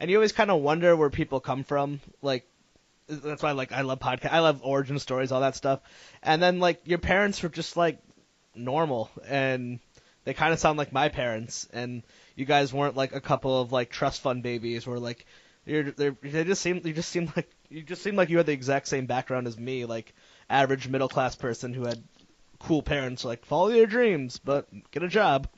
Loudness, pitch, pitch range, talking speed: -27 LUFS, 140 Hz, 130-160 Hz, 220 wpm